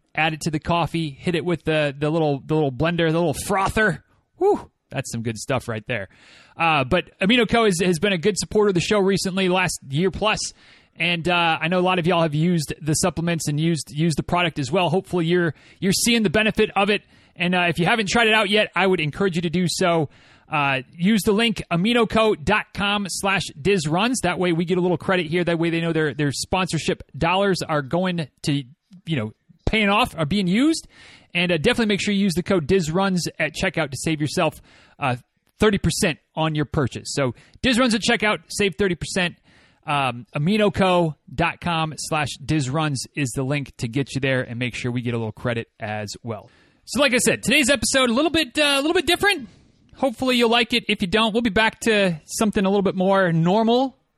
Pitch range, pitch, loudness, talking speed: 155-205 Hz, 175 Hz, -21 LUFS, 215 wpm